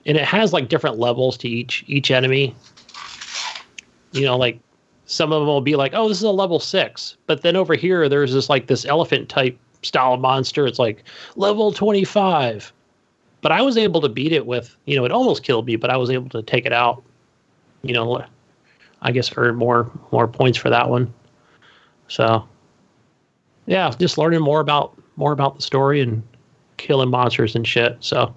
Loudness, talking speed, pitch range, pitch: -19 LUFS, 190 wpm, 120-155 Hz, 135 Hz